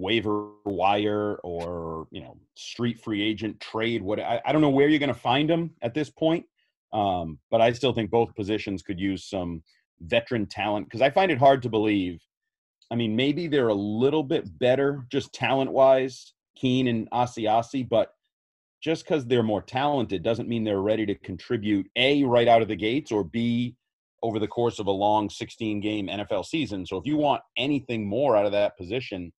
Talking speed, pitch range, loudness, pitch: 195 wpm, 105-135 Hz, -25 LUFS, 115 Hz